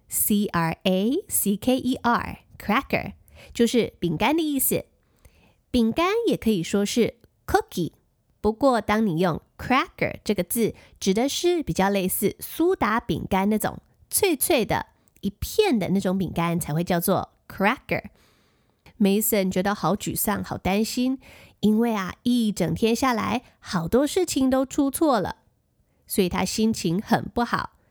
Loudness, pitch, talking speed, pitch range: -24 LUFS, 215 Hz, 260 characters per minute, 190-255 Hz